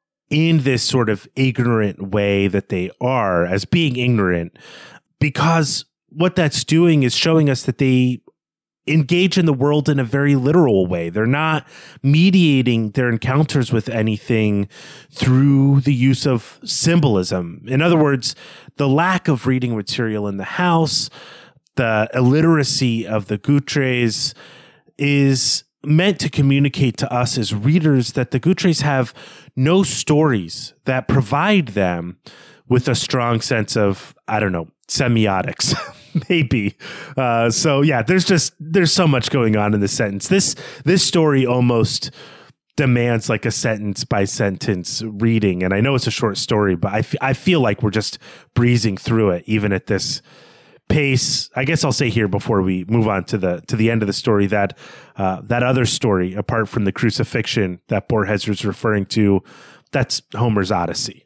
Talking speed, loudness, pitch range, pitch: 160 wpm, -18 LUFS, 110-145 Hz, 125 Hz